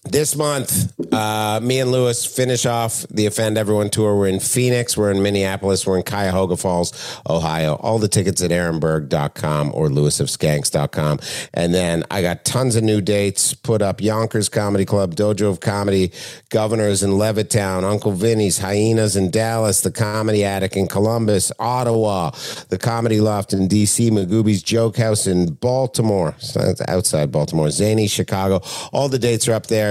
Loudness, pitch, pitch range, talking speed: -18 LUFS, 105 Hz, 95-115 Hz, 160 wpm